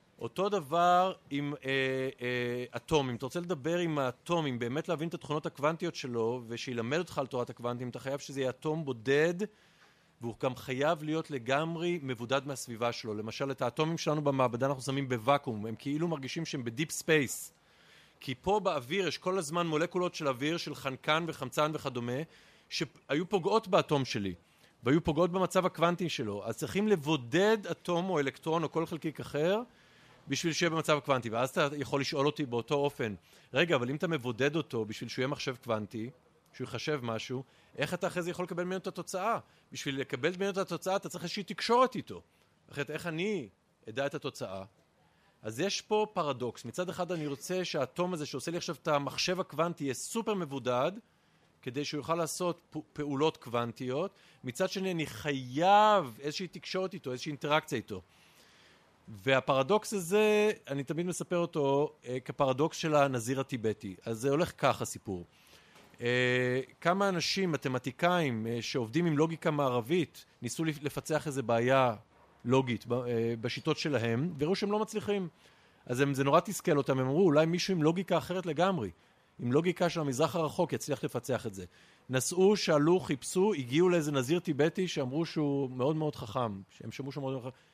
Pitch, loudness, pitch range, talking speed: 150 Hz, -32 LUFS, 130-175 Hz, 165 wpm